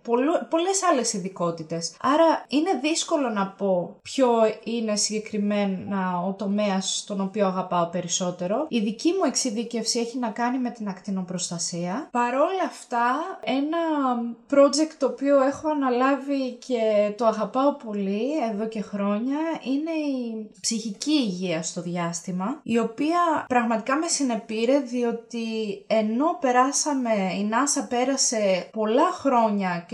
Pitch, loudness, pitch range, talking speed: 235 Hz, -24 LUFS, 205-275 Hz, 120 wpm